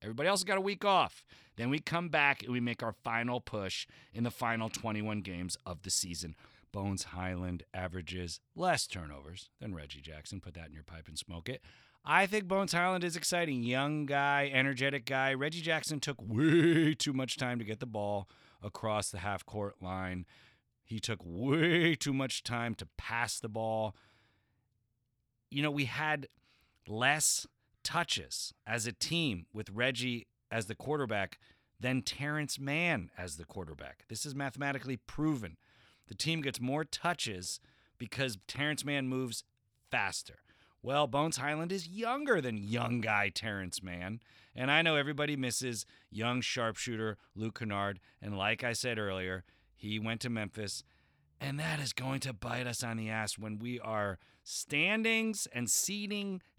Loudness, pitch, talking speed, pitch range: -34 LUFS, 120 Hz, 165 wpm, 100-140 Hz